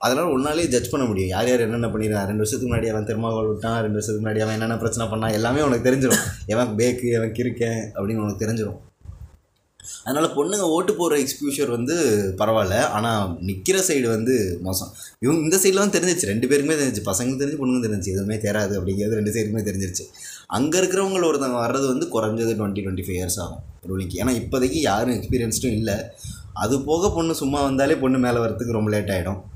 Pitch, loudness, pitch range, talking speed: 115 Hz, -22 LUFS, 105-130 Hz, 185 wpm